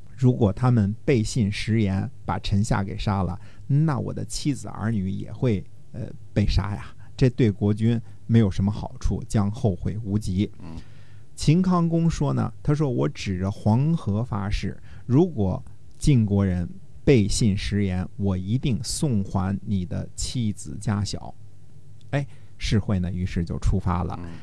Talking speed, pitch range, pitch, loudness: 215 characters per minute, 95-120 Hz, 105 Hz, -25 LUFS